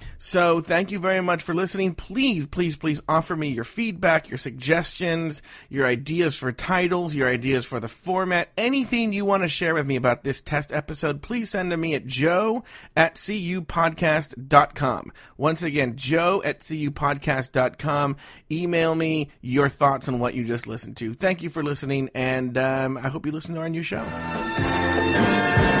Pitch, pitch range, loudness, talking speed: 155 Hz, 130-175 Hz, -24 LUFS, 170 wpm